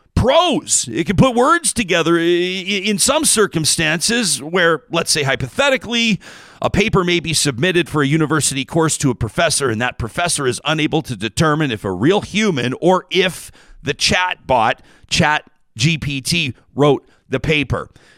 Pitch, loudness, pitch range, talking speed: 160 Hz, -16 LUFS, 135-185 Hz, 150 wpm